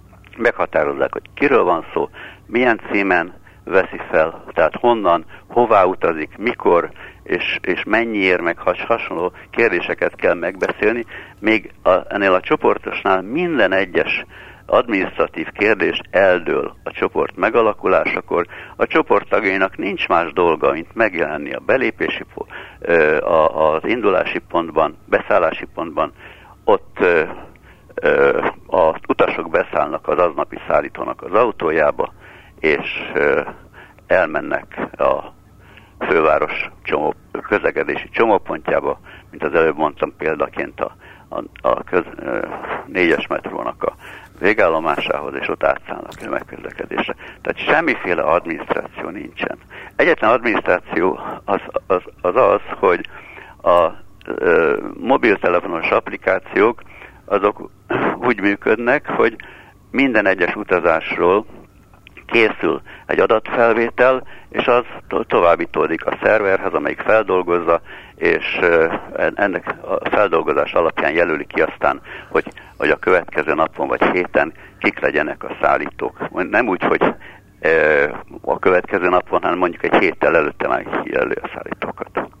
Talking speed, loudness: 110 wpm, -18 LUFS